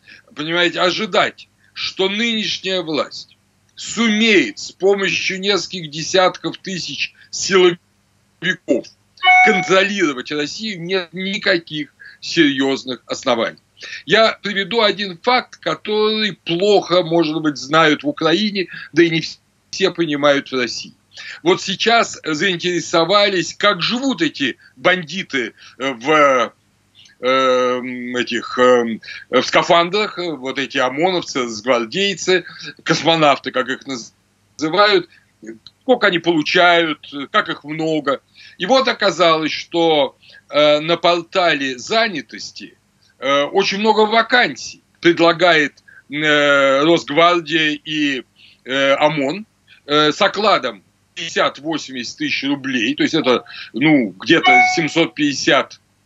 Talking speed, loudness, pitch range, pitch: 90 wpm, -16 LUFS, 145-200 Hz, 170 Hz